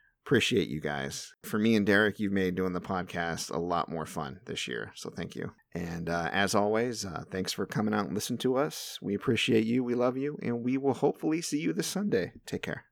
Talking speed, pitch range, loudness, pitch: 230 wpm, 95-130 Hz, -30 LUFS, 110 Hz